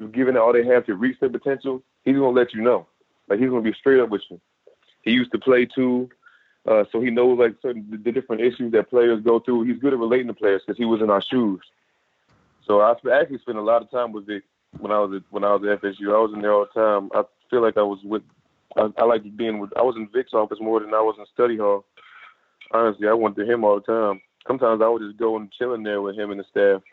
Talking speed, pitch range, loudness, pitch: 275 wpm, 105-125 Hz, -21 LUFS, 115 Hz